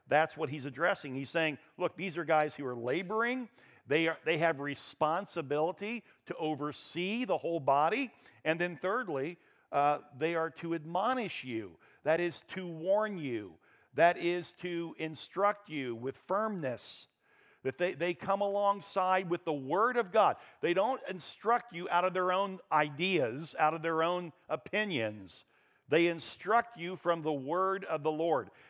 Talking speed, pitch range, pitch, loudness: 160 wpm, 155-185 Hz, 170 Hz, -33 LUFS